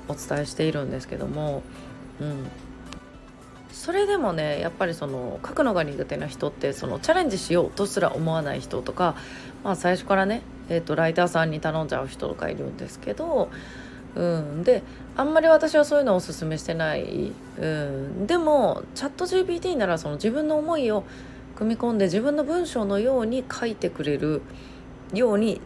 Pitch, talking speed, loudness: 175 Hz, 365 characters per minute, -25 LUFS